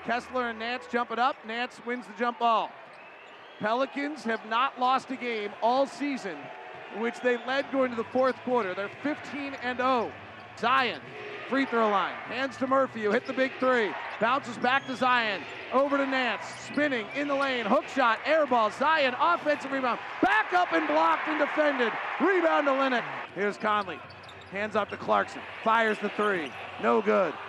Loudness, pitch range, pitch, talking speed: -27 LUFS, 225-275 Hz, 250 Hz, 175 wpm